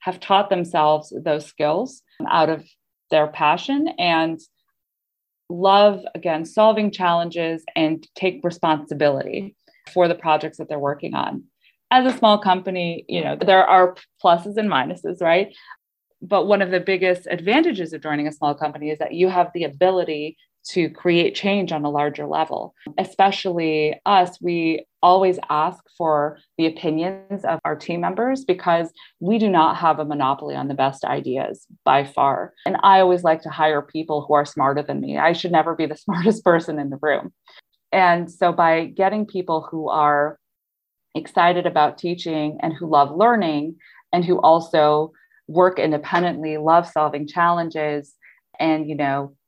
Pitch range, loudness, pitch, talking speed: 155-185 Hz, -20 LUFS, 170 Hz, 160 wpm